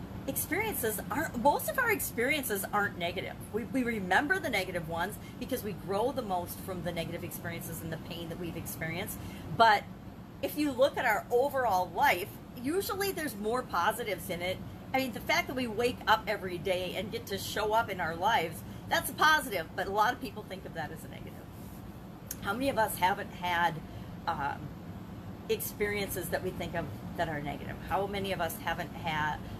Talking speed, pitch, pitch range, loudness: 195 wpm, 200 Hz, 175-245 Hz, -32 LUFS